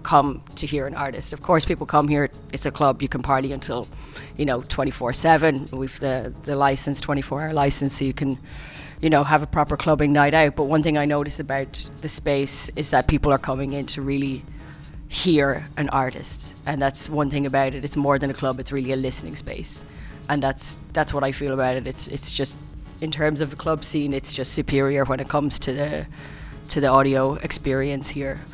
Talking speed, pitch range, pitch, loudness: 210 wpm, 135-150 Hz, 140 Hz, -22 LUFS